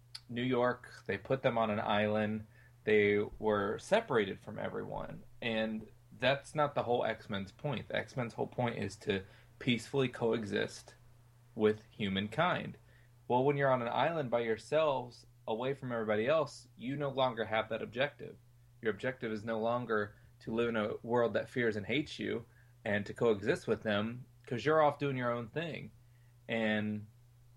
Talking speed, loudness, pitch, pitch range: 170 wpm, -35 LUFS, 120 Hz, 110-125 Hz